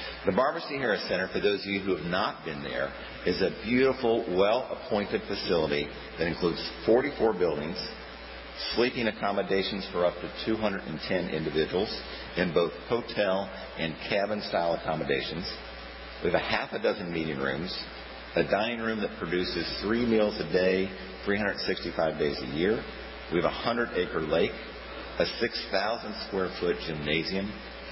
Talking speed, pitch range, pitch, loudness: 140 wpm, 75-100 Hz, 95 Hz, -29 LUFS